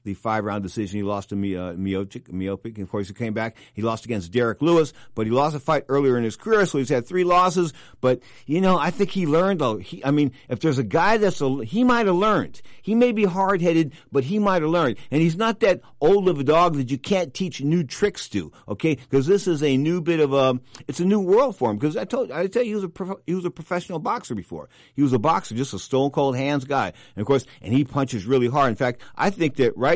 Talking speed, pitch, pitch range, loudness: 275 wpm, 145 Hz, 125-180 Hz, -22 LUFS